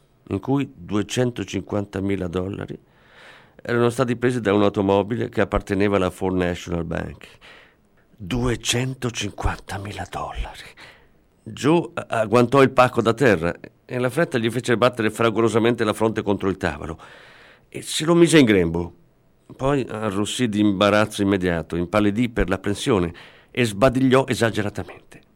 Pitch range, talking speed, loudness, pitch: 95-125 Hz, 125 wpm, -21 LUFS, 105 Hz